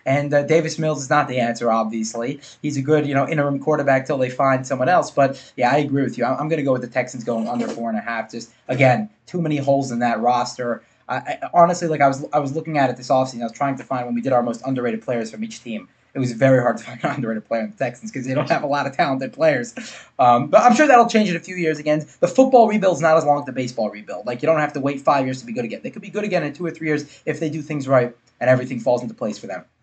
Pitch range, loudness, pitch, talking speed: 125-160 Hz, -20 LUFS, 140 Hz, 310 wpm